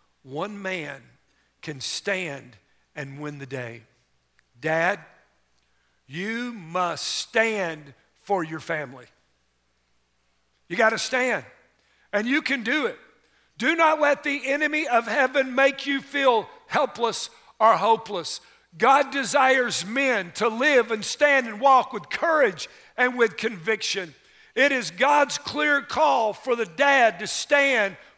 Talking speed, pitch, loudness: 130 wpm, 225 Hz, -23 LUFS